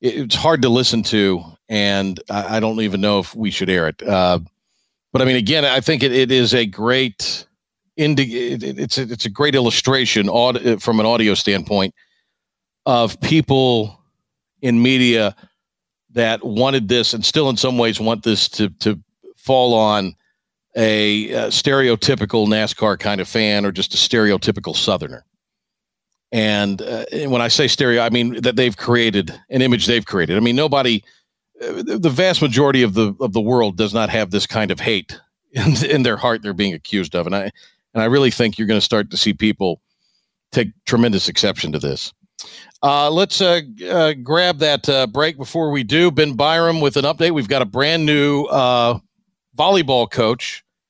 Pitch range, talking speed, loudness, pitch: 105-135 Hz, 180 wpm, -17 LUFS, 120 Hz